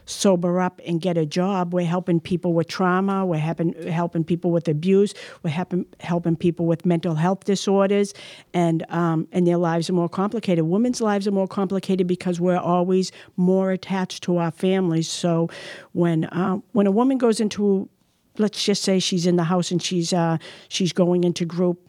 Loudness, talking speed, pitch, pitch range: -22 LUFS, 185 wpm, 180 Hz, 170-190 Hz